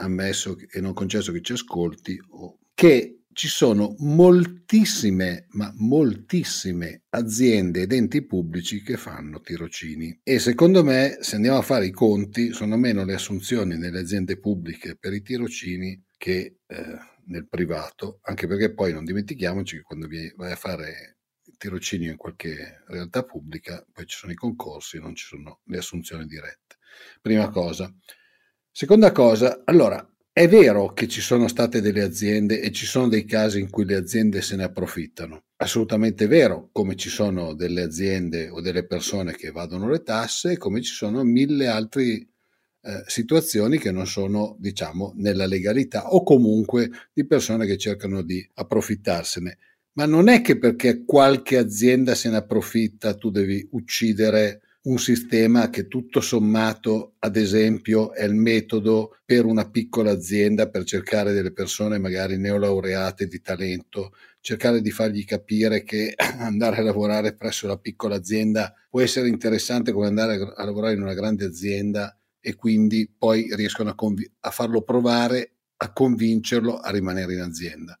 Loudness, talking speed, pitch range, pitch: -22 LUFS, 155 wpm, 95-115 Hz, 105 Hz